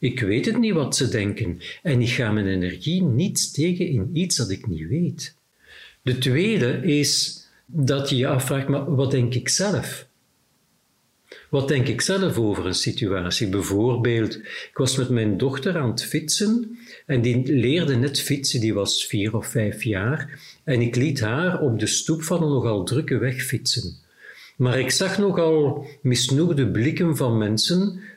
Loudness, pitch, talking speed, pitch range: -22 LUFS, 135 Hz, 170 wpm, 115-155 Hz